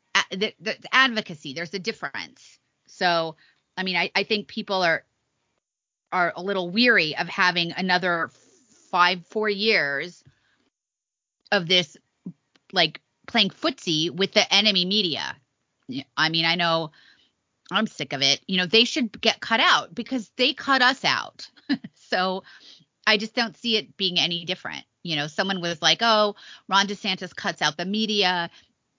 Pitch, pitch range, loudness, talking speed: 190 Hz, 170-215 Hz, -22 LUFS, 155 wpm